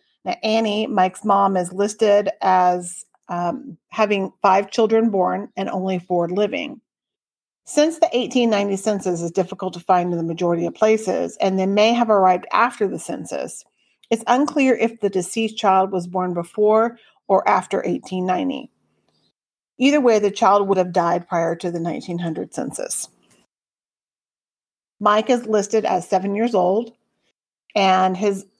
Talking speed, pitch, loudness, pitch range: 145 wpm, 195 Hz, -20 LUFS, 185-220 Hz